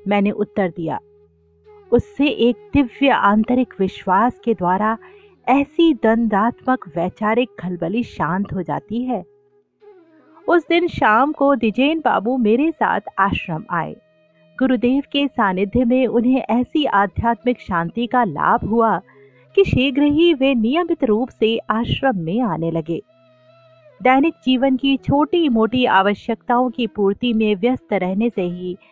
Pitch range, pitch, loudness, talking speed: 195-265 Hz, 235 Hz, -18 LUFS, 130 wpm